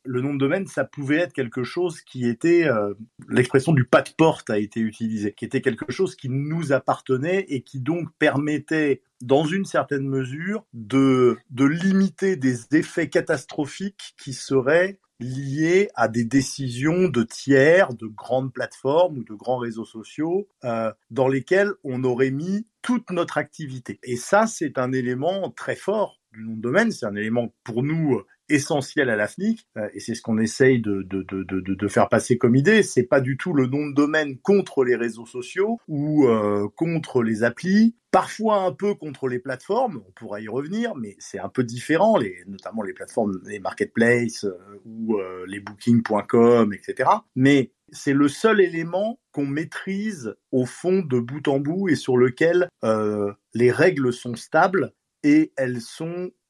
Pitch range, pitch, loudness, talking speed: 120-170 Hz, 135 Hz, -22 LUFS, 175 wpm